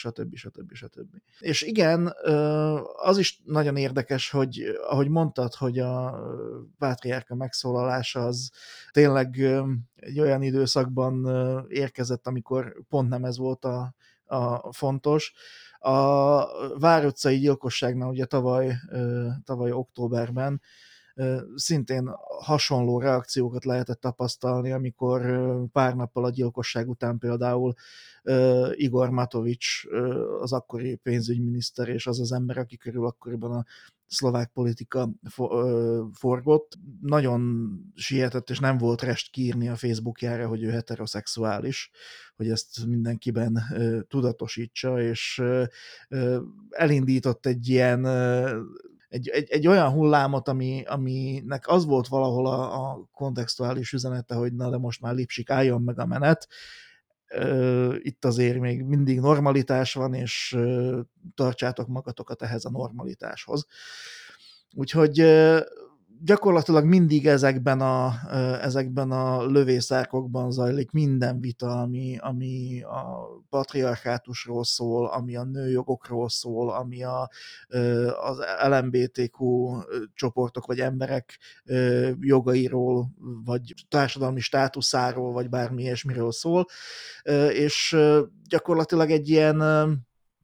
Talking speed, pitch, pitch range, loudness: 105 wpm, 125 Hz, 120-135 Hz, -25 LUFS